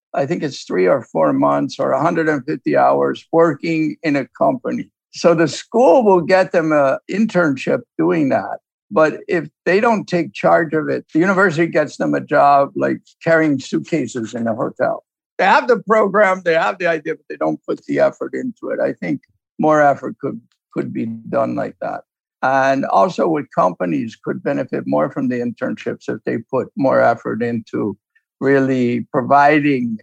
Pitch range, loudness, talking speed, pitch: 130-170 Hz, -17 LUFS, 175 wpm, 155 Hz